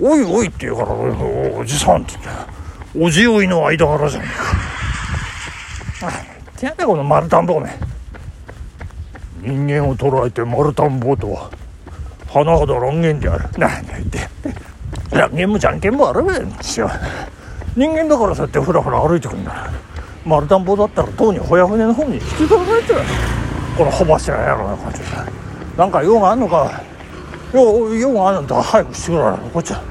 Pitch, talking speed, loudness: 140 Hz, 330 characters per minute, -16 LUFS